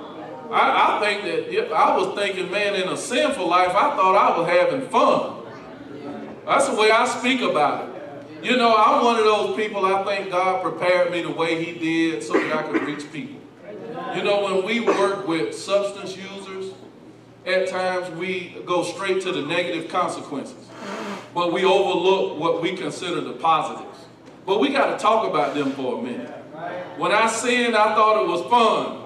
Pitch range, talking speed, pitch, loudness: 175-215 Hz, 190 wpm, 190 Hz, -21 LUFS